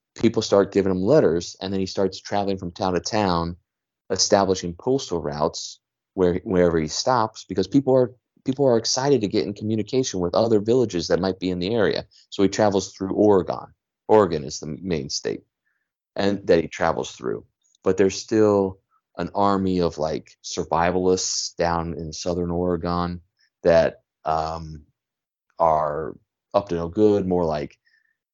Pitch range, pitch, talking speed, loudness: 85-105 Hz, 95 Hz, 160 wpm, -22 LUFS